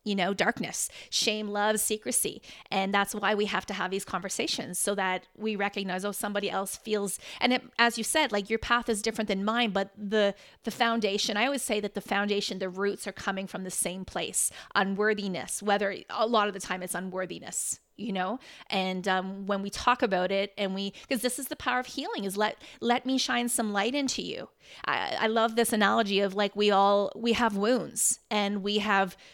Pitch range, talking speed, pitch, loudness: 195-230 Hz, 215 wpm, 205 Hz, -28 LUFS